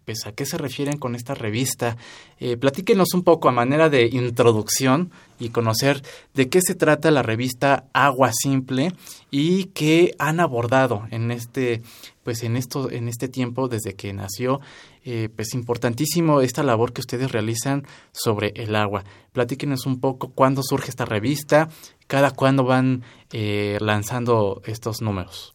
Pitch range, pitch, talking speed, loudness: 115-140 Hz, 130 Hz, 155 wpm, -22 LUFS